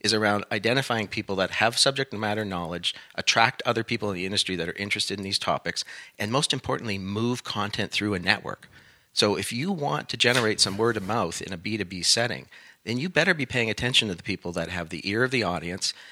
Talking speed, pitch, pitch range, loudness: 220 wpm, 105 Hz, 100-120 Hz, -25 LUFS